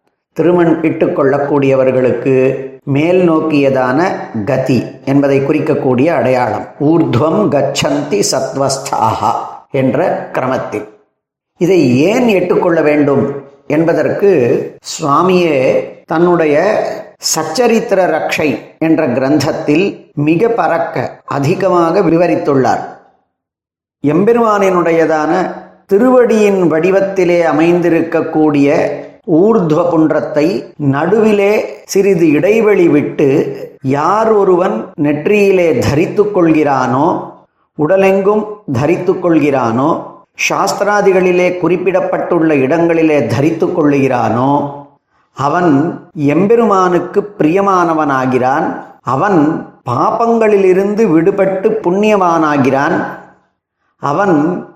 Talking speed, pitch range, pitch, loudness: 60 wpm, 145-195 Hz, 165 Hz, -12 LUFS